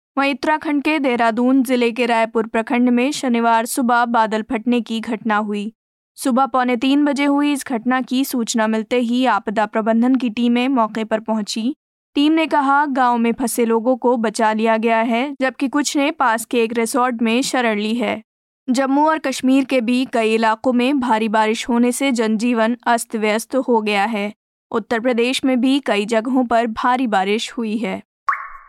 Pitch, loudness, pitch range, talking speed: 240 Hz, -18 LUFS, 225-260 Hz, 180 wpm